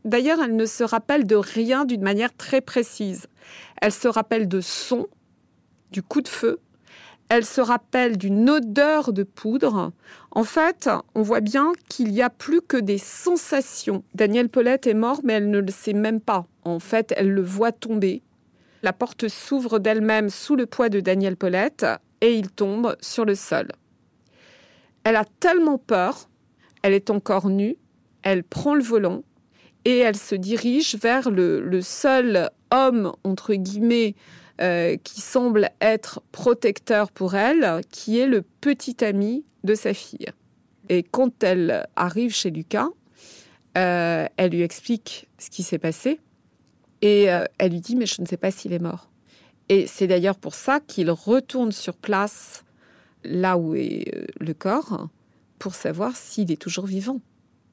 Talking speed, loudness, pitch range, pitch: 165 wpm, -22 LUFS, 195-245 Hz, 220 Hz